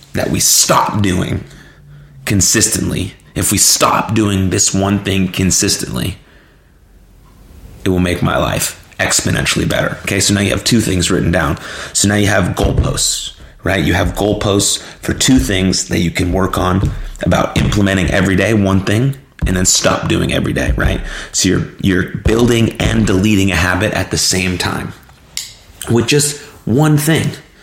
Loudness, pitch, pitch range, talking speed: -13 LUFS, 95 Hz, 90-110 Hz, 165 wpm